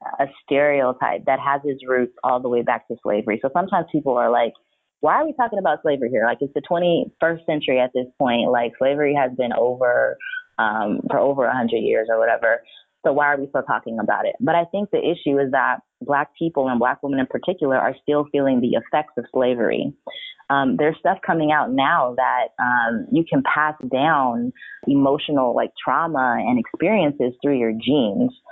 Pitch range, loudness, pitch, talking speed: 130-170 Hz, -20 LUFS, 145 Hz, 195 wpm